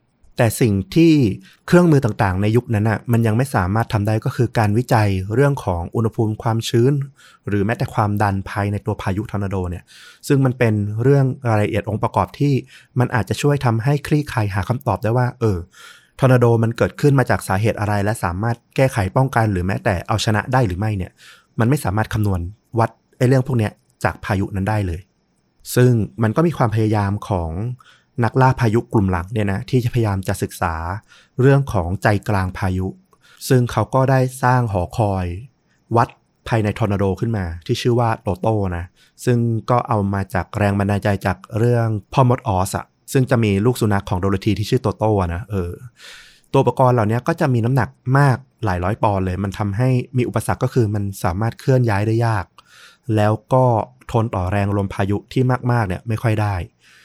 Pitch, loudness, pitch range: 110 Hz, -19 LUFS, 100-125 Hz